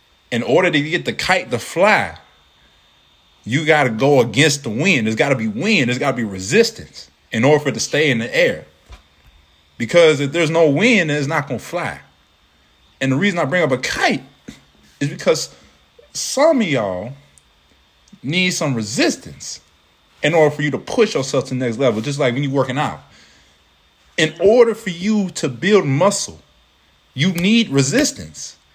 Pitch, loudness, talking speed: 140 Hz, -17 LUFS, 185 wpm